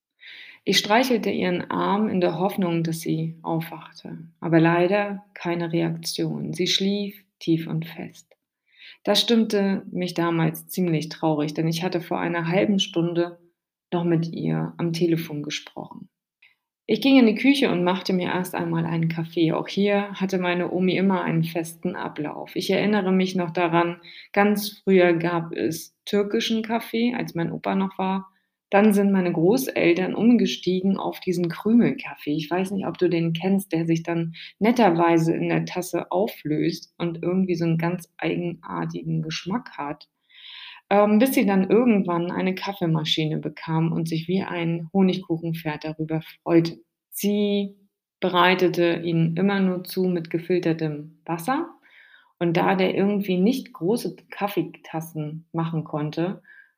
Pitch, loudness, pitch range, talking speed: 175 Hz, -23 LUFS, 165-200 Hz, 145 wpm